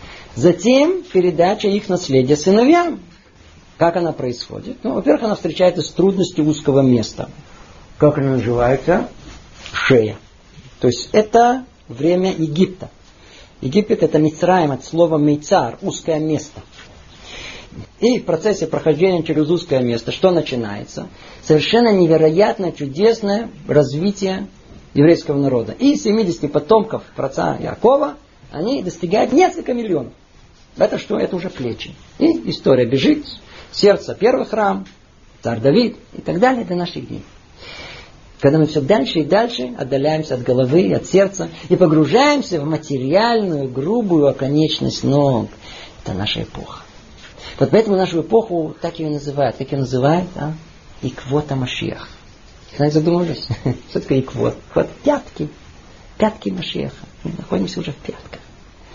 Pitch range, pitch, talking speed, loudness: 145-200 Hz, 165 Hz, 125 wpm, -17 LUFS